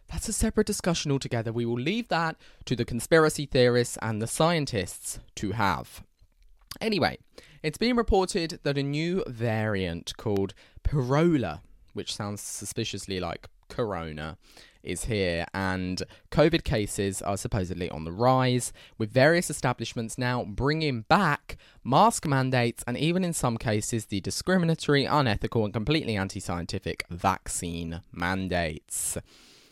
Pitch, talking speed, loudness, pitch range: 115 Hz, 130 wpm, -27 LUFS, 95-150 Hz